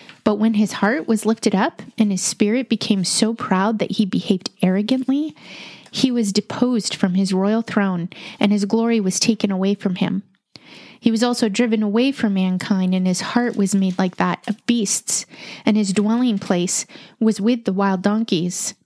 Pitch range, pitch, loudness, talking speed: 195-230 Hz, 215 Hz, -19 LUFS, 180 wpm